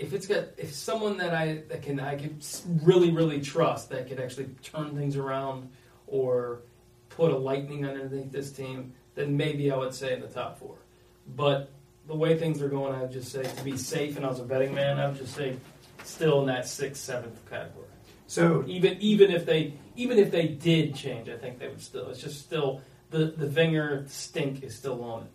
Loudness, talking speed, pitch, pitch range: -29 LUFS, 215 wpm, 140 Hz, 130-155 Hz